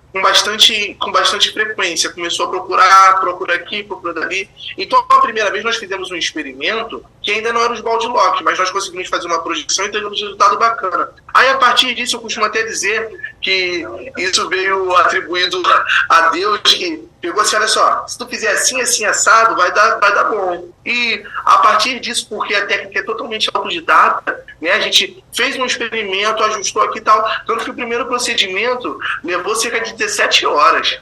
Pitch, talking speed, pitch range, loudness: 215 Hz, 190 wpm, 190-245 Hz, -14 LUFS